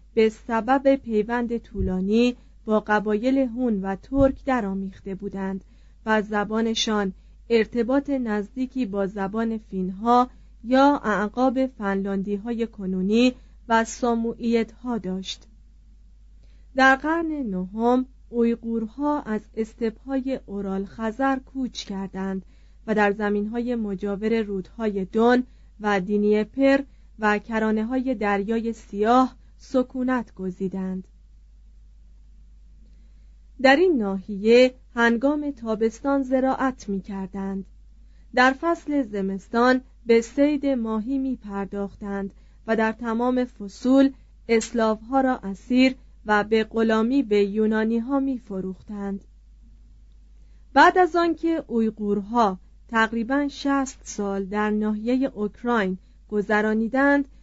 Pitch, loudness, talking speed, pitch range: 225 Hz, -23 LUFS, 100 wpm, 200-255 Hz